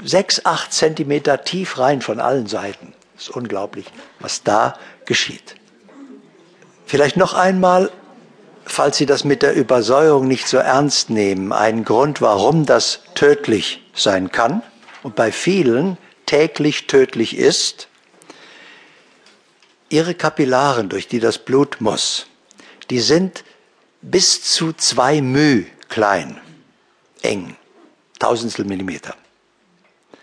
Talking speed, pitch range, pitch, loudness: 115 wpm, 130-160 Hz, 145 Hz, -16 LUFS